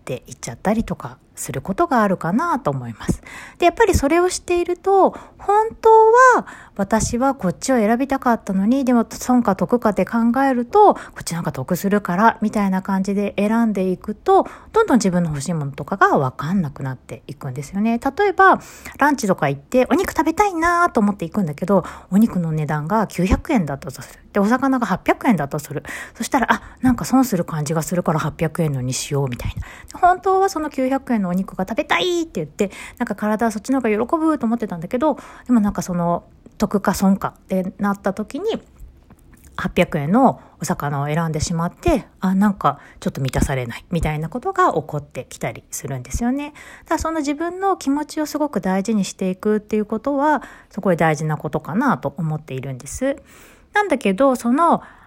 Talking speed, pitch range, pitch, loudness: 400 characters per minute, 170-270 Hz, 205 Hz, -19 LUFS